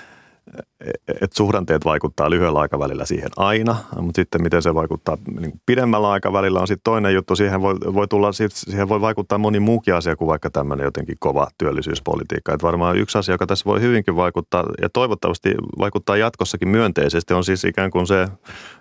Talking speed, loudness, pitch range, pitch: 170 wpm, -19 LUFS, 85-105 Hz, 95 Hz